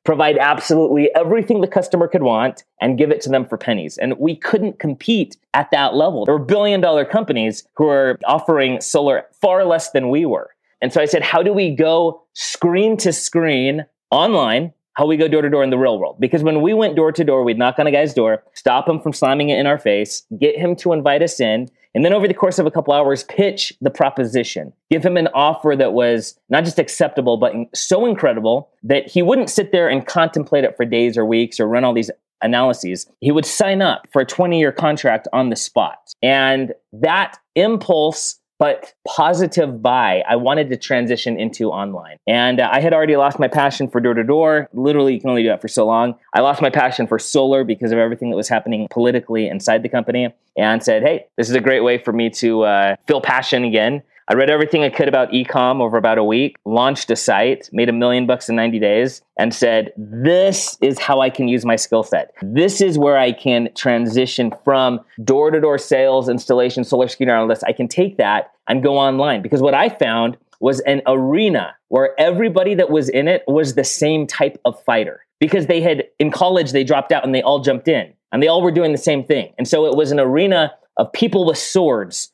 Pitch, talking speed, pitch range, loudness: 140 Hz, 220 wpm, 120-160 Hz, -16 LUFS